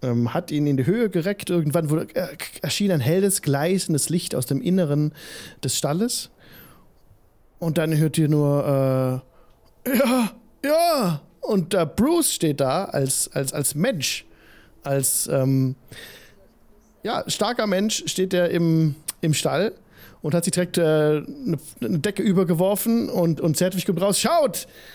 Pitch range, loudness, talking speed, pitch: 145-190 Hz, -22 LUFS, 145 wpm, 170 Hz